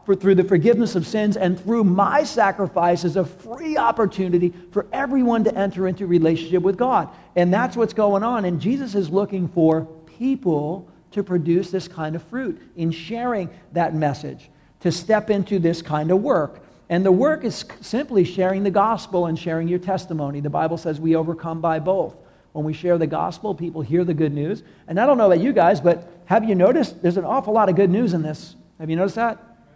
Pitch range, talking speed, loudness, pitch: 165-205 Hz, 210 wpm, -21 LUFS, 185 Hz